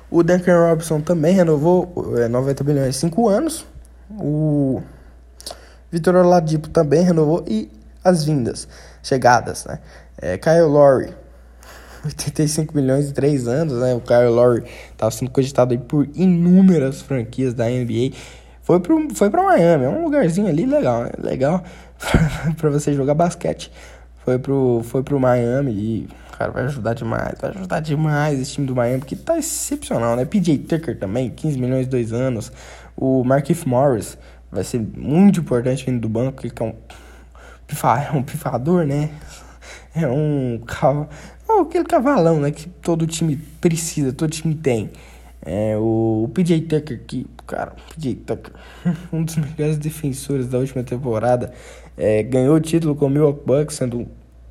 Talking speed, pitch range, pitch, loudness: 155 wpm, 120-160 Hz, 140 Hz, -19 LUFS